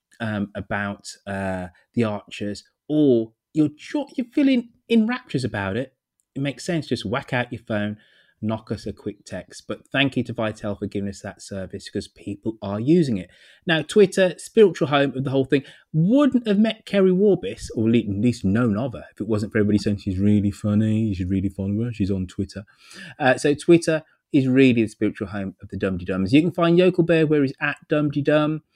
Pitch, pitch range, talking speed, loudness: 120 Hz, 100-155 Hz, 205 wpm, -22 LUFS